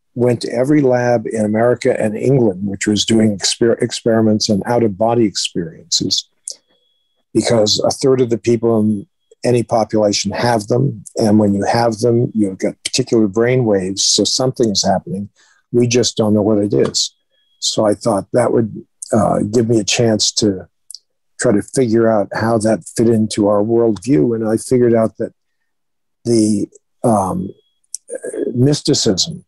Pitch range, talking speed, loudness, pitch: 105-120 Hz, 160 wpm, -15 LUFS, 115 Hz